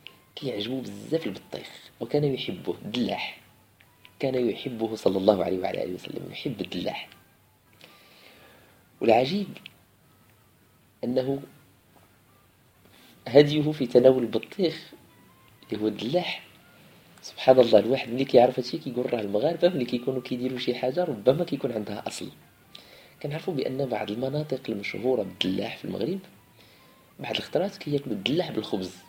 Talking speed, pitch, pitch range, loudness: 120 wpm, 125 Hz, 110-140 Hz, -26 LUFS